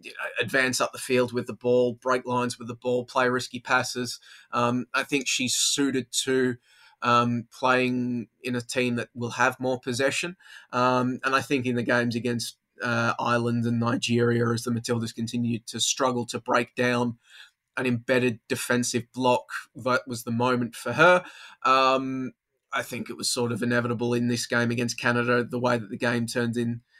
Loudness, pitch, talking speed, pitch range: -25 LUFS, 120 Hz, 180 wpm, 120-125 Hz